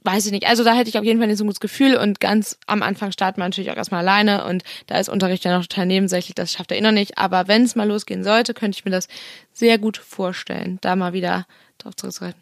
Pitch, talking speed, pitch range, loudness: 200 Hz, 280 wpm, 185-220 Hz, -19 LUFS